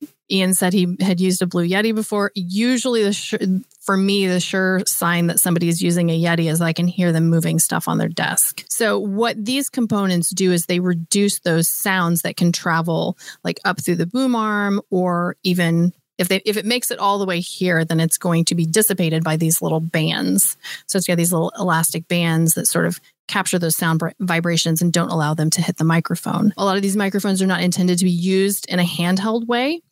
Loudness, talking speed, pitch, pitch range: -18 LUFS, 225 wpm, 180 Hz, 170-200 Hz